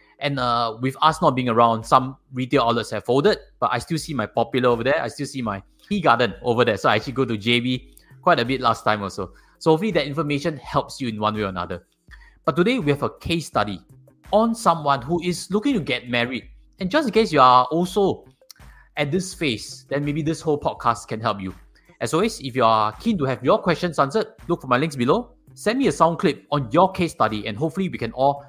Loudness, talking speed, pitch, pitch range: -21 LUFS, 240 wpm, 135 Hz, 120-165 Hz